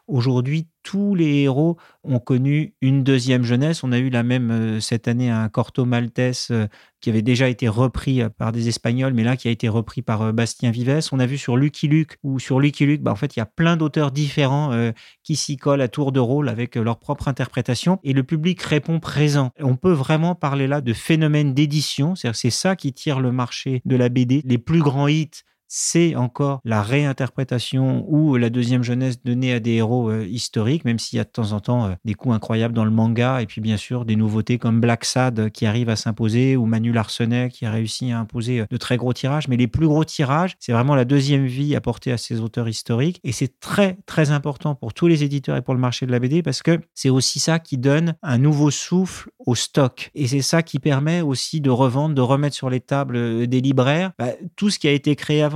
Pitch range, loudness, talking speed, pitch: 120-145 Hz, -20 LUFS, 235 wpm, 130 Hz